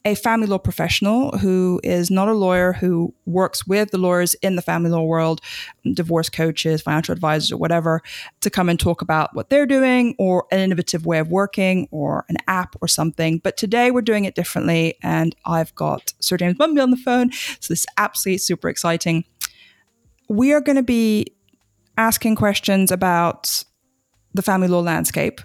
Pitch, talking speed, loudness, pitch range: 180 Hz, 180 wpm, -19 LUFS, 165-210 Hz